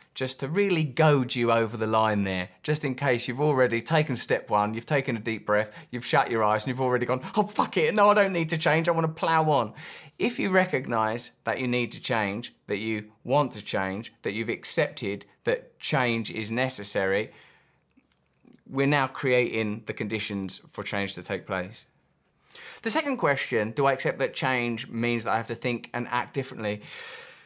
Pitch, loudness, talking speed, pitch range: 120 Hz, -26 LUFS, 195 wpm, 110-145 Hz